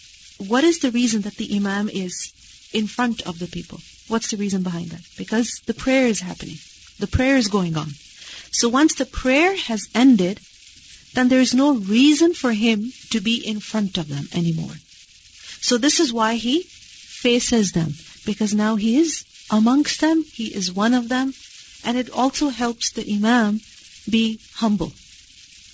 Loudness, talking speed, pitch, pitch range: -20 LUFS, 175 wpm, 225 Hz, 200-255 Hz